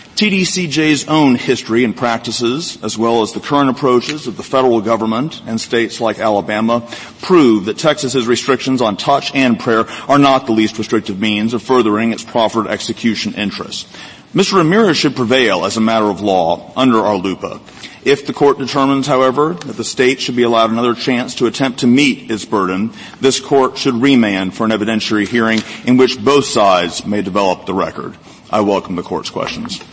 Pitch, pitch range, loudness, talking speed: 125 Hz, 110-140 Hz, -14 LUFS, 180 wpm